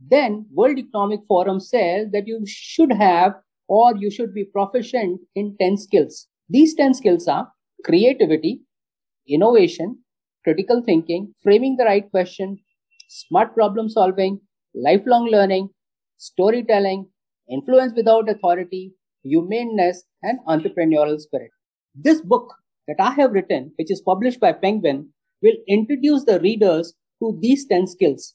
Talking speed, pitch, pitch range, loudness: 130 wpm, 205 Hz, 190-245 Hz, -19 LUFS